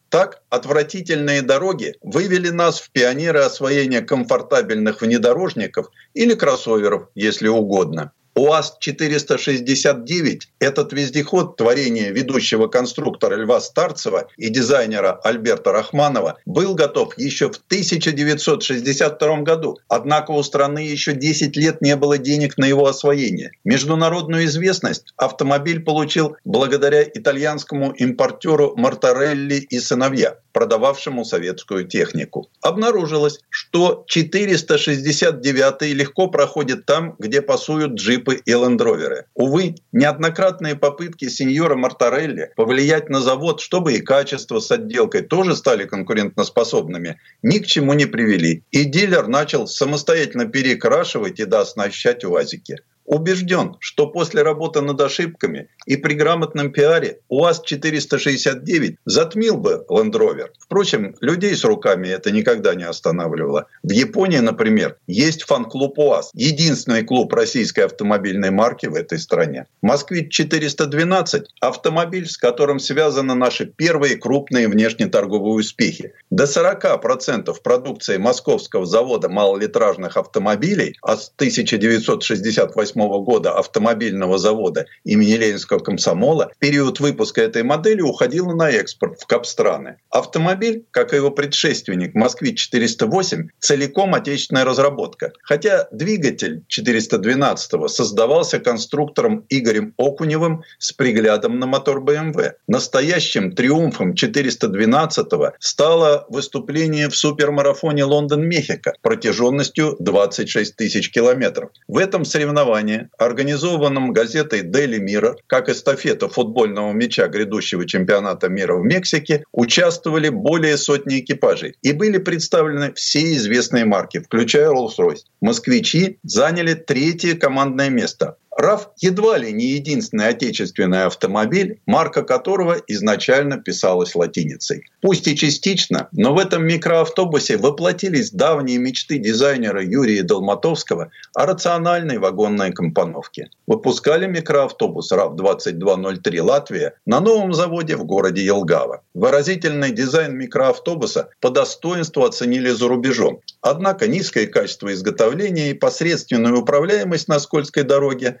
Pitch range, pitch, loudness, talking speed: 140-195 Hz, 155 Hz, -18 LUFS, 110 wpm